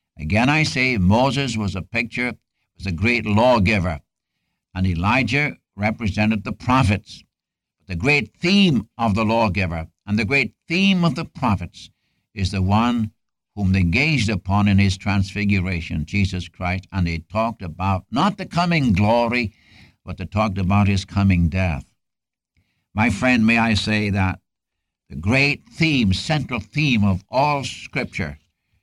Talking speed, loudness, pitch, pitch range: 145 wpm, -20 LUFS, 105 Hz, 95-120 Hz